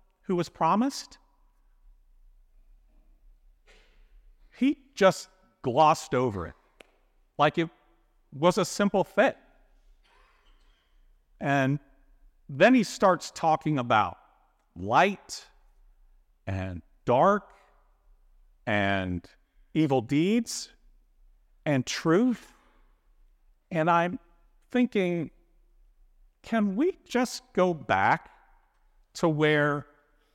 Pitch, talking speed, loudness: 150 Hz, 75 wpm, -26 LUFS